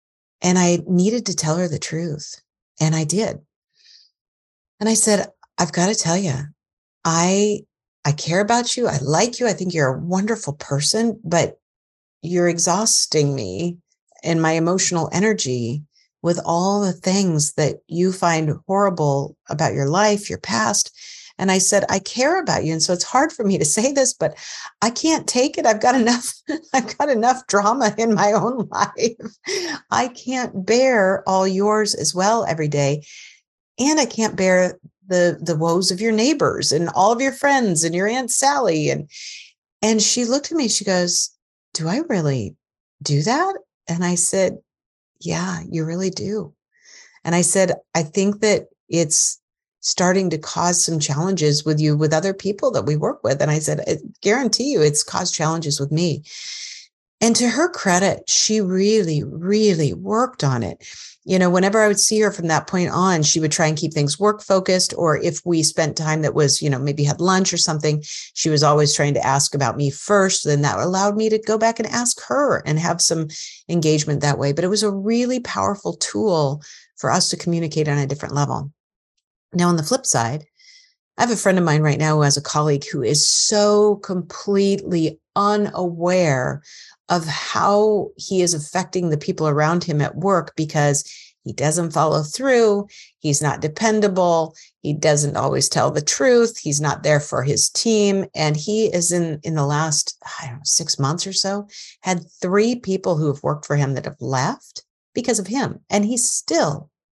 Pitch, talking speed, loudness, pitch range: 180 Hz, 185 wpm, -19 LUFS, 155-215 Hz